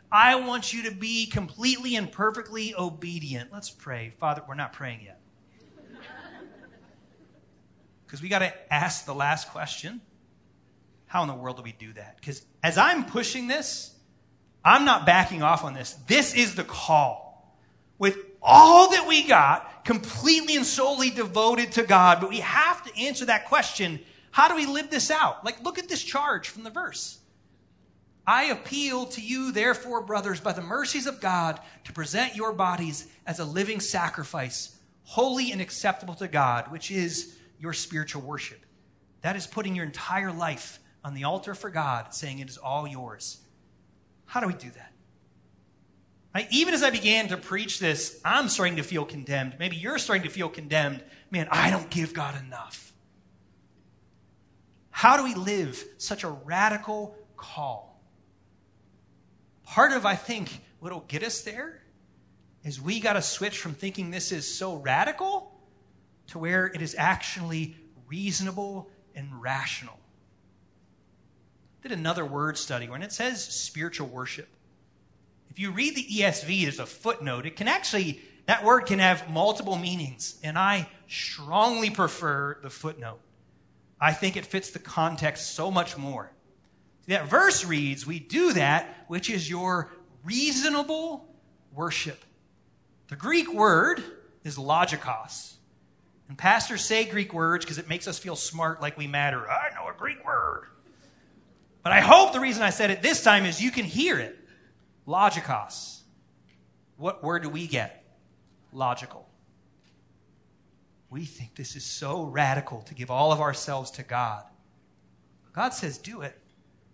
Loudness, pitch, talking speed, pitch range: -25 LUFS, 175 Hz, 155 wpm, 140-215 Hz